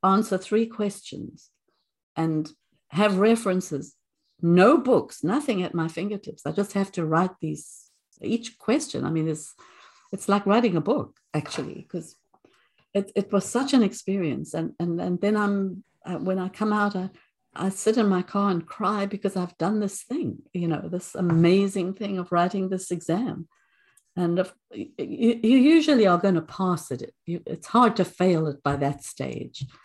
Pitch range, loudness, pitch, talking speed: 175-210 Hz, -25 LUFS, 190 Hz, 170 wpm